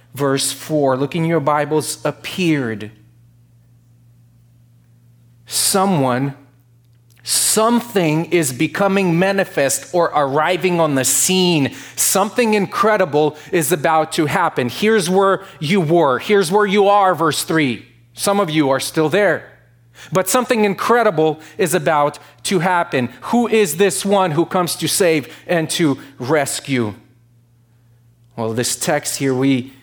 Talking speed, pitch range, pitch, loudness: 125 wpm, 125-185 Hz, 155 Hz, -16 LUFS